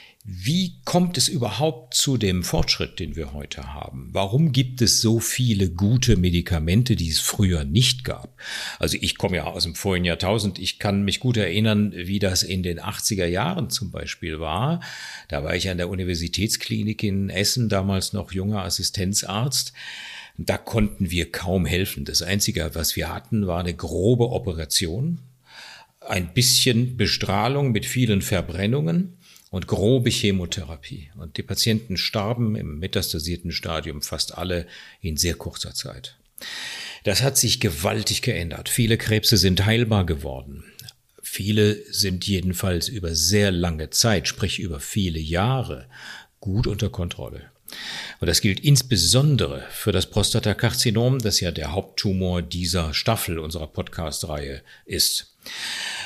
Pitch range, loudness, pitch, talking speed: 85-115 Hz, -22 LUFS, 100 Hz, 145 wpm